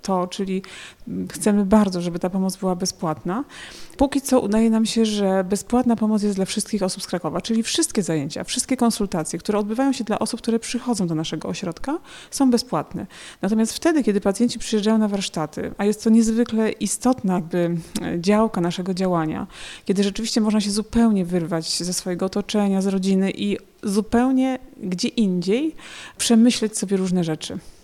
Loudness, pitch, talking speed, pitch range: -22 LUFS, 205 Hz, 160 wpm, 185-230 Hz